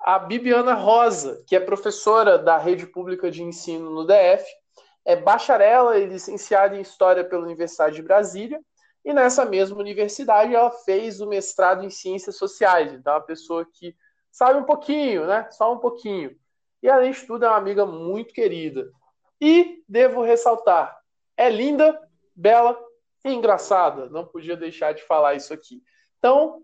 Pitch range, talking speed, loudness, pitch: 185-255 Hz, 160 wpm, -20 LUFS, 210 Hz